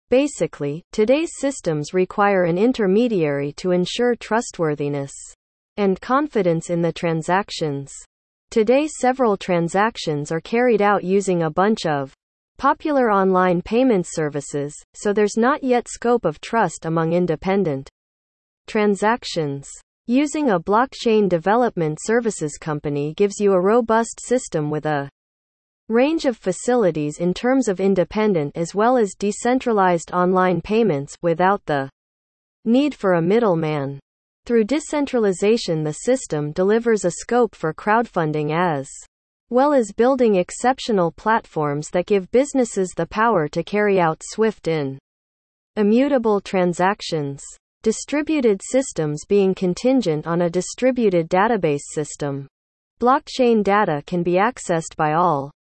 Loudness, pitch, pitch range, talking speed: -20 LUFS, 190 Hz, 160-230 Hz, 120 wpm